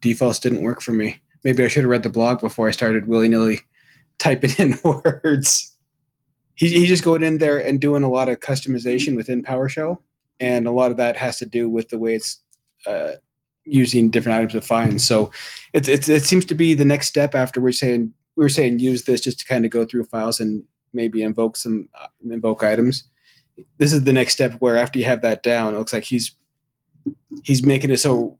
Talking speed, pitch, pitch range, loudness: 215 wpm, 125 Hz, 115-140 Hz, -19 LUFS